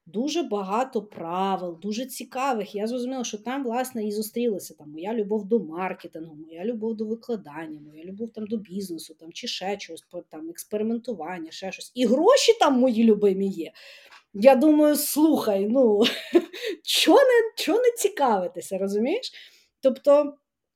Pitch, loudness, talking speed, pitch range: 225 Hz, -24 LUFS, 135 wpm, 185-260 Hz